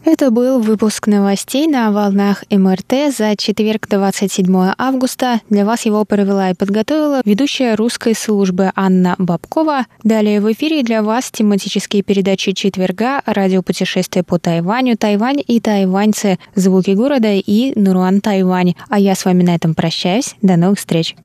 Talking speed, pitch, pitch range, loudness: 145 wpm, 205 Hz, 190-230 Hz, -14 LUFS